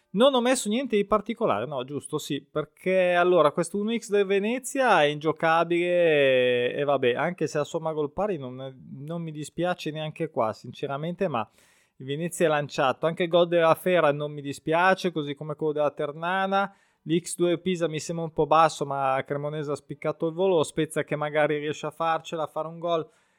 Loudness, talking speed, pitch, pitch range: -26 LUFS, 190 wpm, 160 Hz, 150-175 Hz